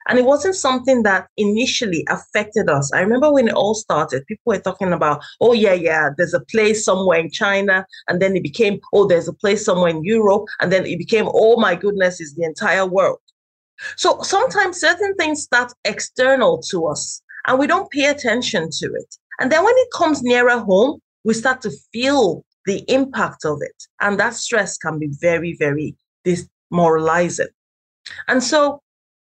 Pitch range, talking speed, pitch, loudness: 180-265 Hz, 185 wpm, 215 Hz, -17 LUFS